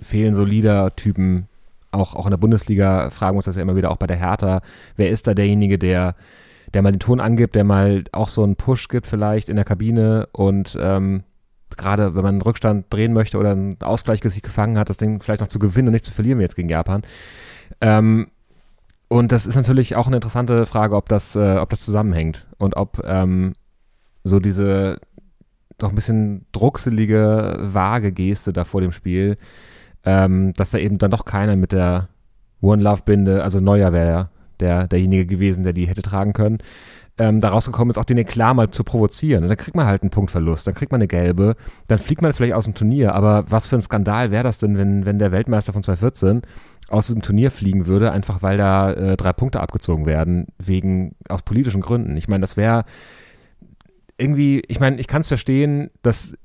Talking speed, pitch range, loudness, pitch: 205 wpm, 95-110 Hz, -18 LUFS, 100 Hz